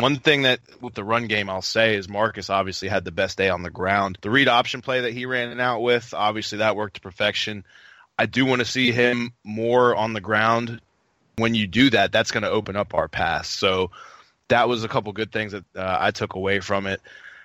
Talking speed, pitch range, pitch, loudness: 235 wpm, 100-120 Hz, 110 Hz, -22 LUFS